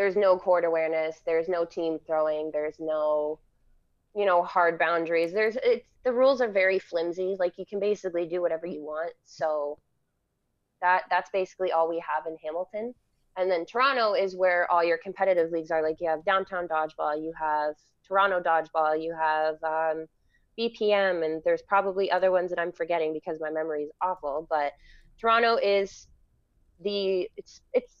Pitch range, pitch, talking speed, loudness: 155-190 Hz, 170 Hz, 170 wpm, -27 LUFS